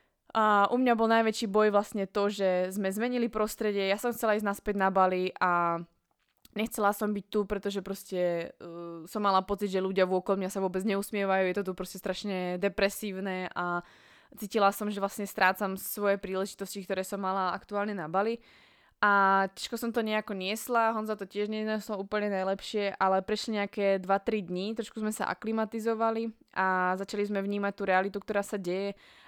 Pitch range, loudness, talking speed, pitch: 190-215 Hz, -30 LUFS, 180 wpm, 200 Hz